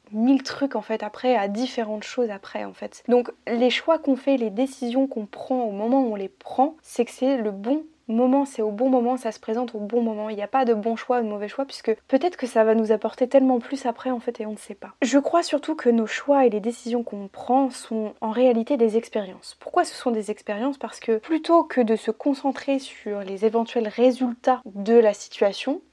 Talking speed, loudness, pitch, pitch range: 245 wpm, -23 LUFS, 240 Hz, 220-265 Hz